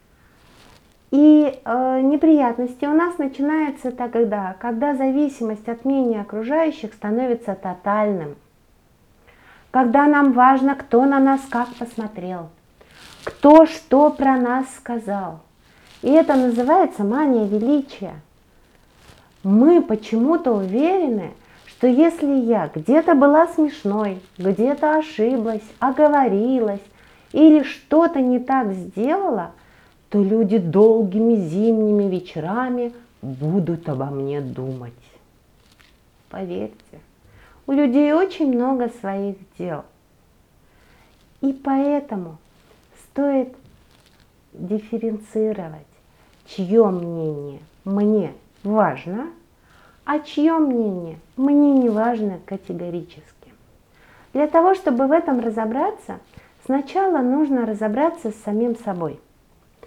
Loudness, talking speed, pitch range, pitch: -19 LUFS, 90 wpm, 195-280 Hz, 235 Hz